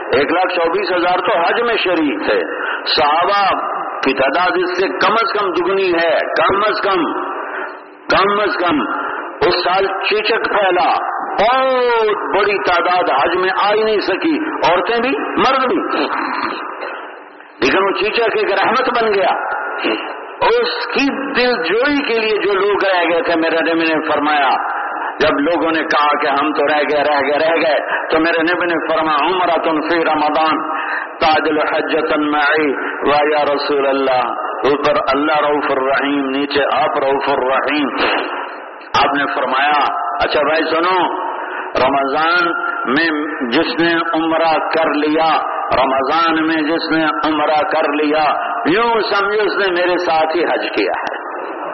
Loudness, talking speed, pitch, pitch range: -15 LUFS, 145 wpm, 165 Hz, 150-205 Hz